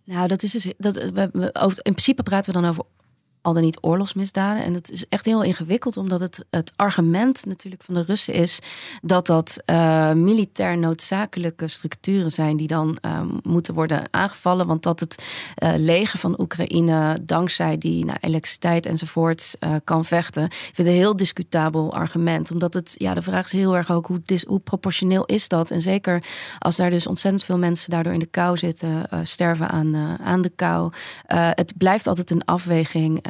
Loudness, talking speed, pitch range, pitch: -21 LUFS, 195 wpm, 165-190 Hz, 175 Hz